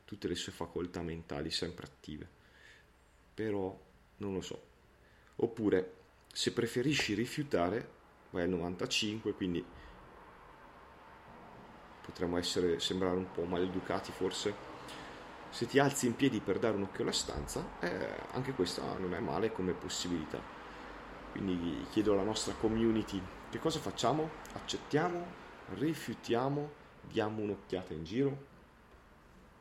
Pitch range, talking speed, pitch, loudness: 90-115 Hz, 120 wpm, 95 Hz, -36 LUFS